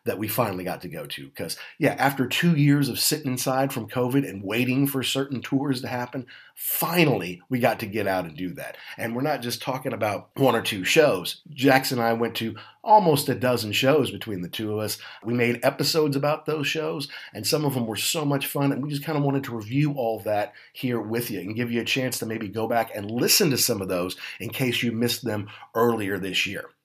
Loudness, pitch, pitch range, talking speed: -24 LUFS, 125 Hz, 110-140 Hz, 240 wpm